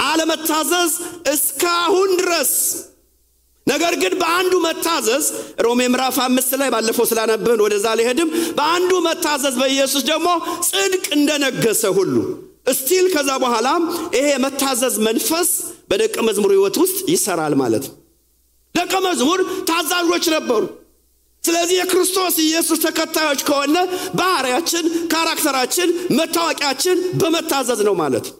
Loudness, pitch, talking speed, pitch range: -17 LUFS, 335 Hz, 105 wpm, 280-360 Hz